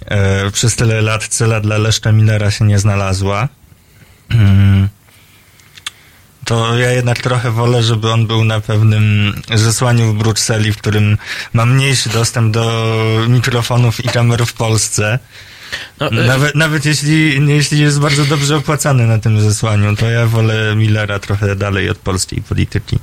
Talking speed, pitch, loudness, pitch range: 140 wpm, 110 Hz, -13 LUFS, 105-120 Hz